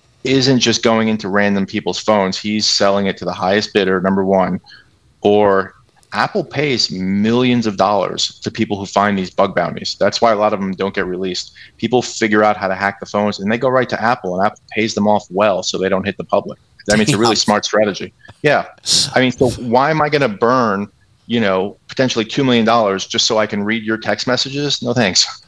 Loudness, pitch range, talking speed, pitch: -16 LUFS, 95-120 Hz, 225 wpm, 105 Hz